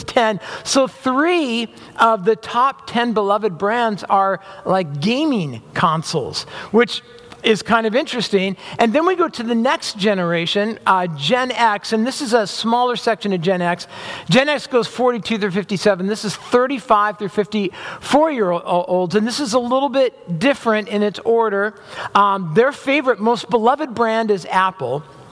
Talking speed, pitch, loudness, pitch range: 165 wpm, 225 Hz, -18 LUFS, 195-245 Hz